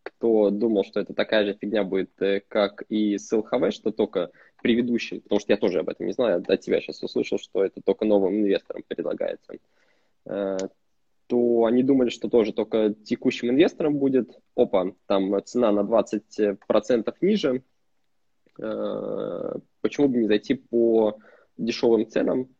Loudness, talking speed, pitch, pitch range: -24 LUFS, 150 wpm, 115 Hz, 105-130 Hz